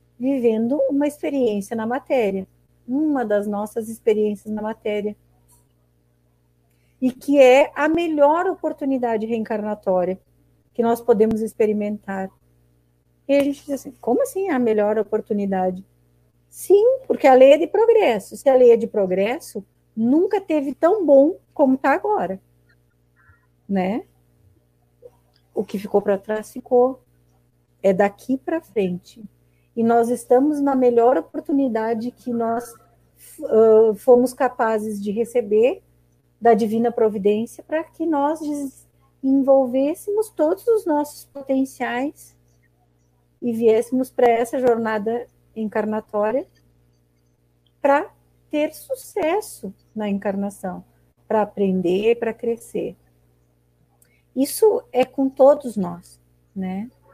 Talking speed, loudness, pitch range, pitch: 115 wpm, -20 LUFS, 185-270 Hz, 225 Hz